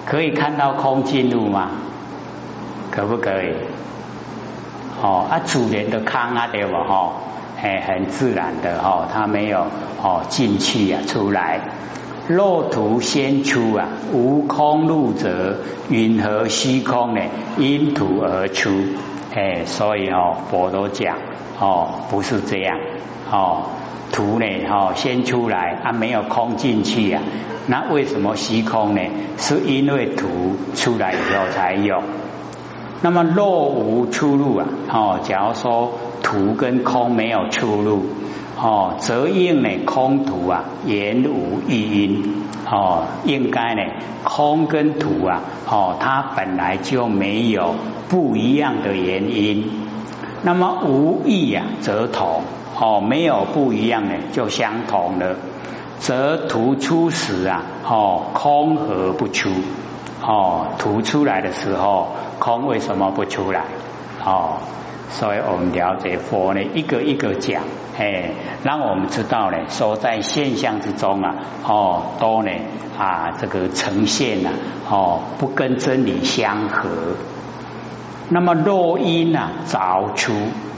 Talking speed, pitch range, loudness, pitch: 185 characters per minute, 100-140 Hz, -19 LUFS, 115 Hz